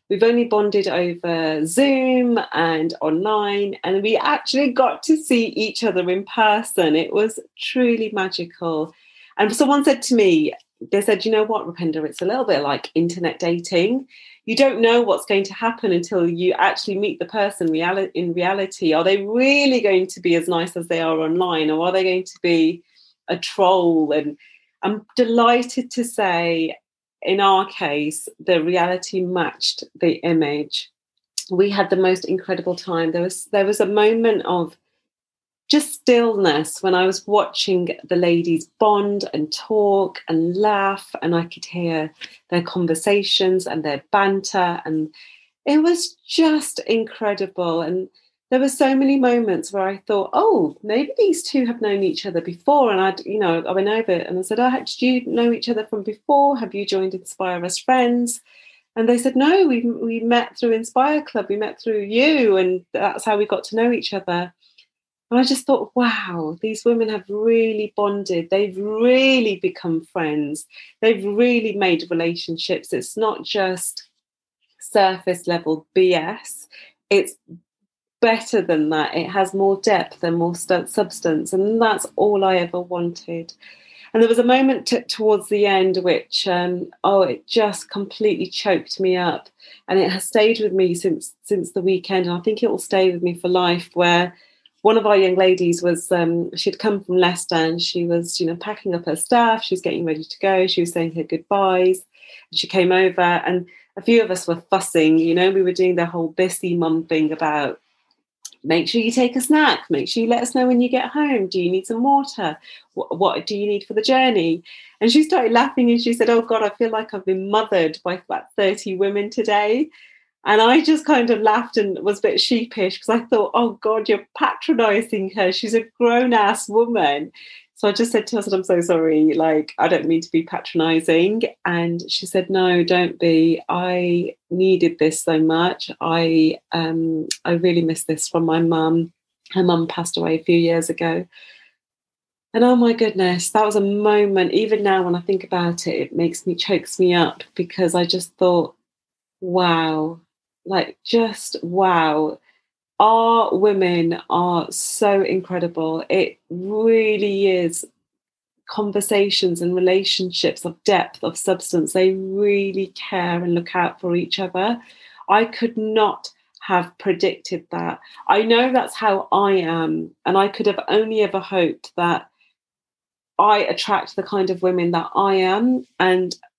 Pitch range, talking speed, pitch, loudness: 175-225 Hz, 180 wpm, 190 Hz, -19 LUFS